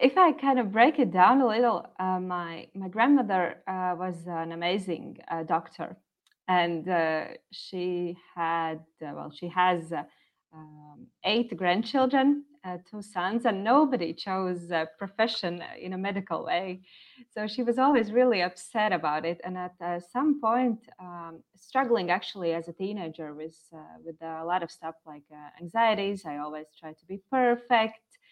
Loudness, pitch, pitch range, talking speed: -27 LUFS, 180 Hz, 165-230 Hz, 165 wpm